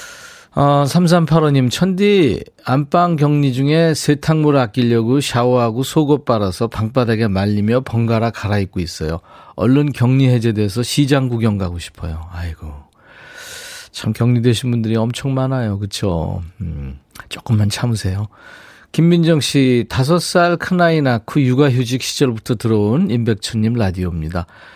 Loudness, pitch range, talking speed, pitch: -16 LUFS, 105-145 Hz, 285 characters per minute, 120 Hz